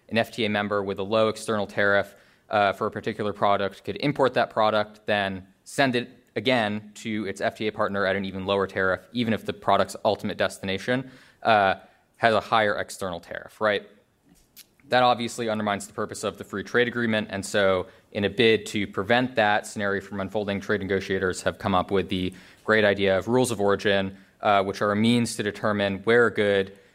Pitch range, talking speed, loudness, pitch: 95-110 Hz, 195 wpm, -25 LUFS, 105 Hz